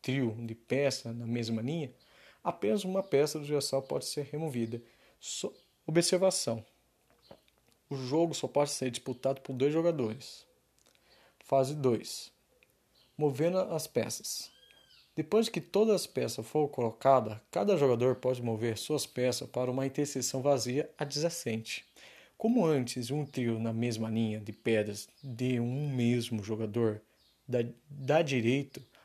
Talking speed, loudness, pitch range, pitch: 130 wpm, -32 LUFS, 115-150 Hz, 130 Hz